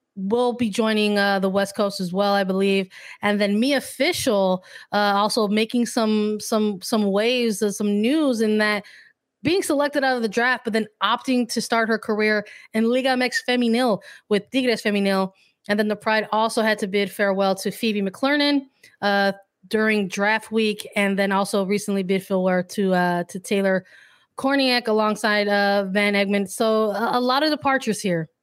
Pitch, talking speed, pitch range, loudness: 210 Hz, 180 wpm, 200-235 Hz, -21 LUFS